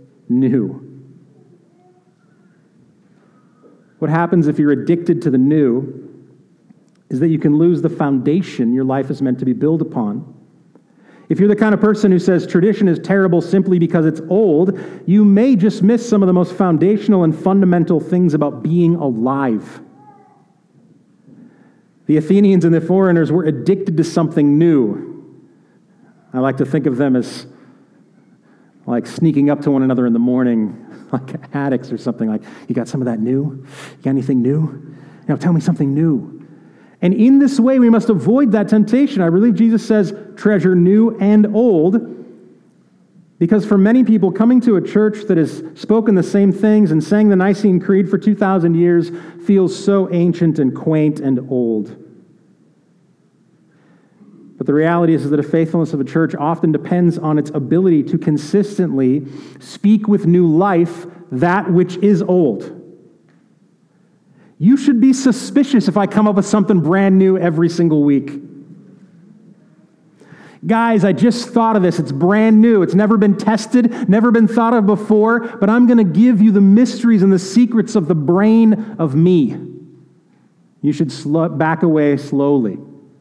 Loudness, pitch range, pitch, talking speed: -14 LUFS, 155-205 Hz, 180 Hz, 165 wpm